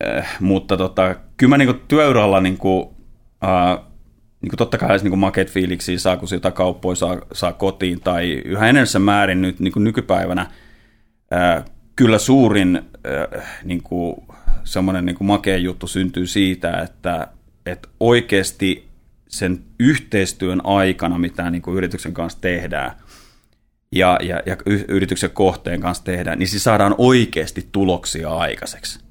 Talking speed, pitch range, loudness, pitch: 130 wpm, 90-100 Hz, -18 LUFS, 95 Hz